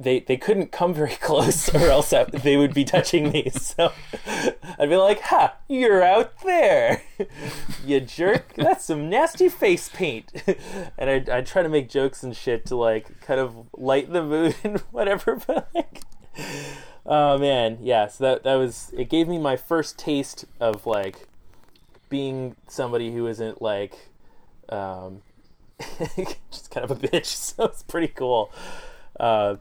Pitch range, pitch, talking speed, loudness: 130-195 Hz, 145 Hz, 160 wpm, -23 LUFS